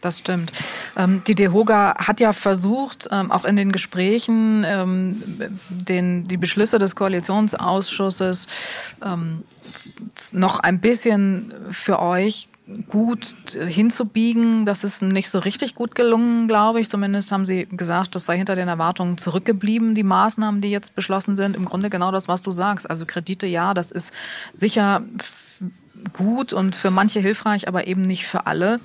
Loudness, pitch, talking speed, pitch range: -20 LUFS, 195 Hz, 145 wpm, 185-215 Hz